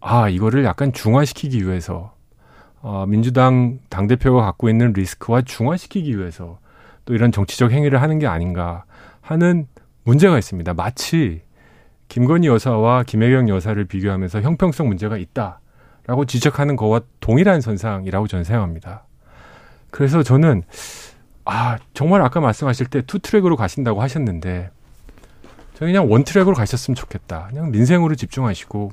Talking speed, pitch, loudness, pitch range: 345 characters per minute, 120 Hz, -18 LUFS, 100-140 Hz